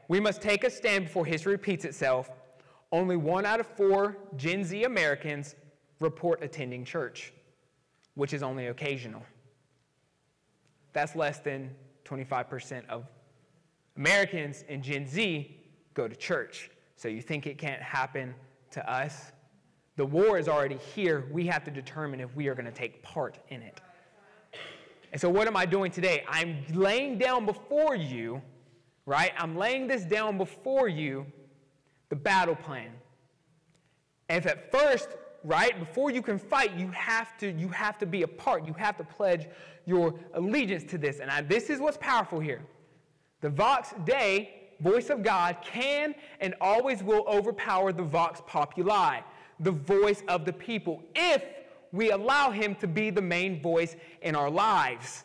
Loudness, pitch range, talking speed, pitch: -29 LUFS, 145-205 Hz, 160 wpm, 170 Hz